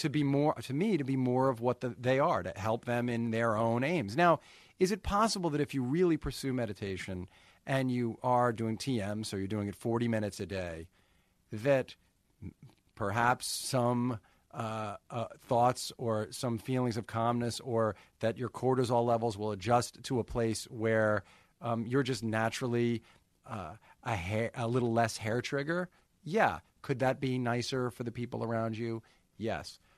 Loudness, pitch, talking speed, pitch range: -33 LUFS, 120 Hz, 175 wpm, 110-130 Hz